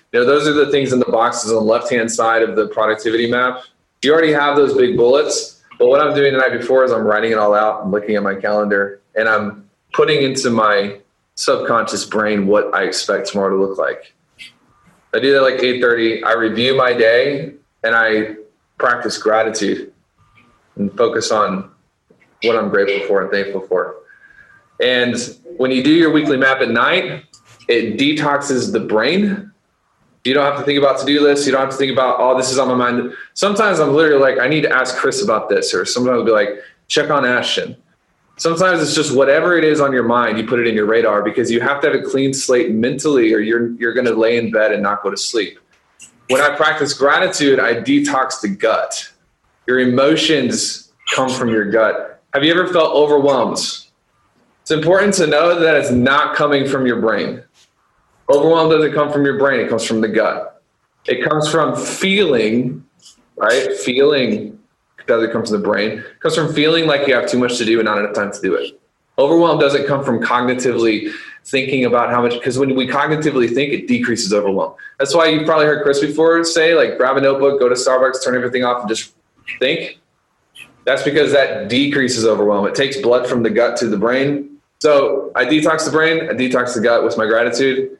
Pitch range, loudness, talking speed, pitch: 115-155 Hz, -15 LUFS, 205 wpm, 130 Hz